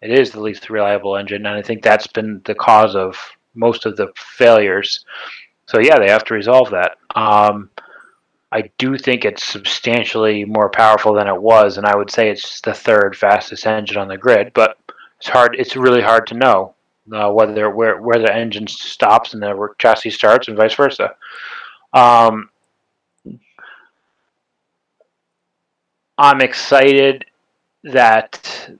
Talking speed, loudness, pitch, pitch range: 155 wpm, -14 LUFS, 110 Hz, 105-120 Hz